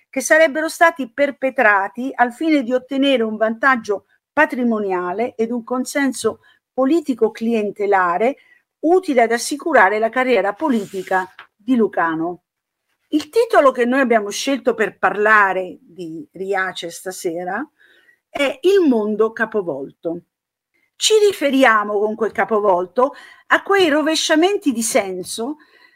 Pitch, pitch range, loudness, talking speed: 245 Hz, 205-295 Hz, -17 LUFS, 110 wpm